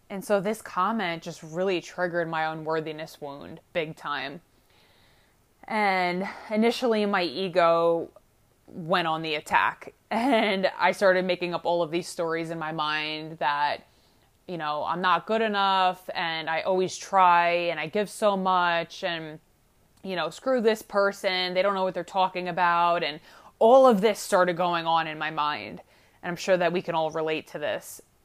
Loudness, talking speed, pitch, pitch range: -25 LUFS, 170 wpm, 175 Hz, 160-190 Hz